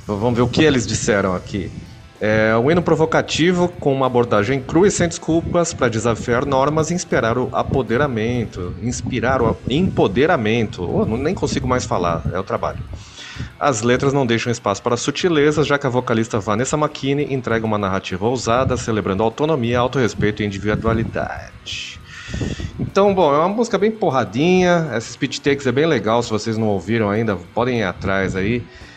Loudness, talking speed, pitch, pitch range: -18 LUFS, 170 wpm, 120 Hz, 110-145 Hz